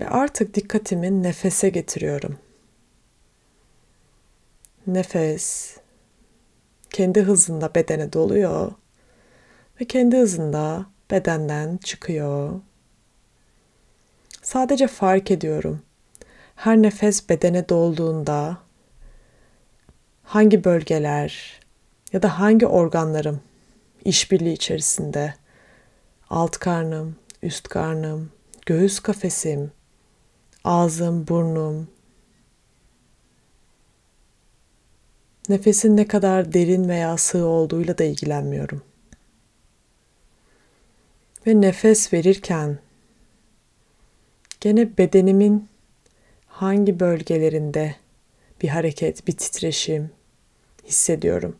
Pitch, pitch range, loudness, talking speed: 175 Hz, 160-200 Hz, -20 LUFS, 70 wpm